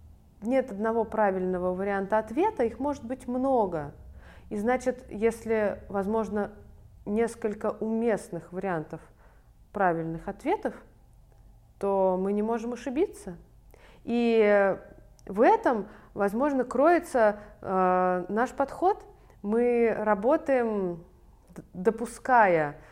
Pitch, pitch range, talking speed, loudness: 220 Hz, 190-245 Hz, 90 wpm, -27 LUFS